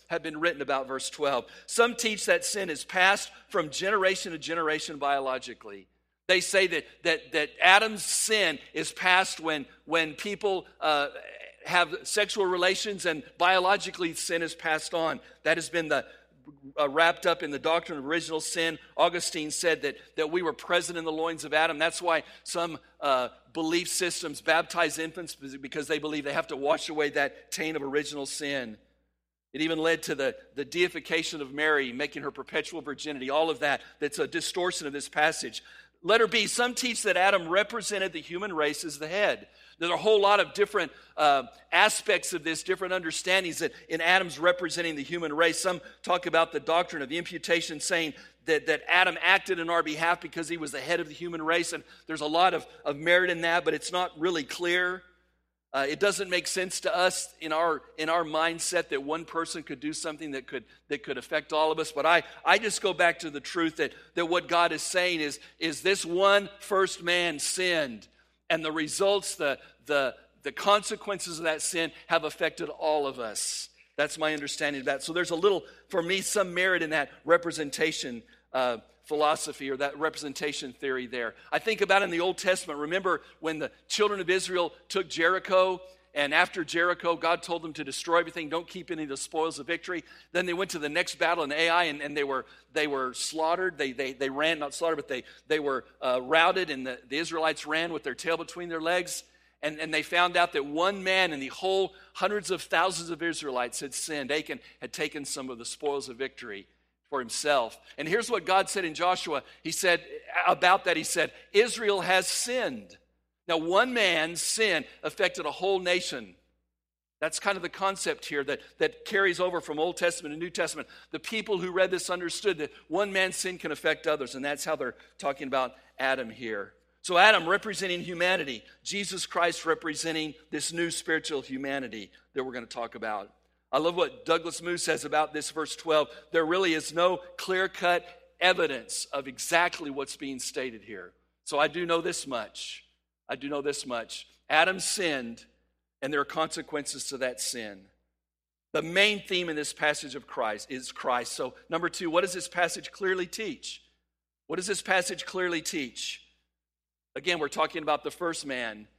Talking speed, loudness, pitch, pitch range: 195 wpm, -28 LUFS, 165 Hz, 150-180 Hz